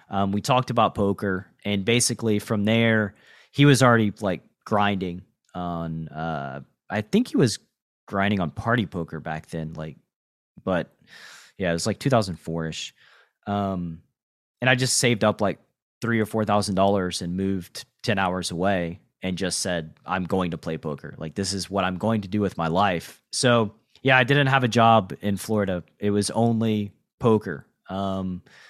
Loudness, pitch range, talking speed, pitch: -24 LUFS, 90-110 Hz, 170 wpm, 100 Hz